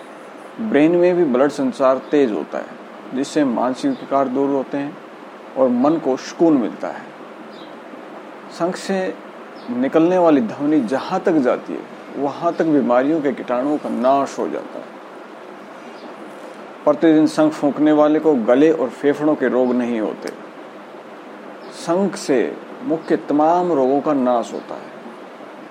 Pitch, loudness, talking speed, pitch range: 150 Hz, -18 LUFS, 140 wpm, 140-170 Hz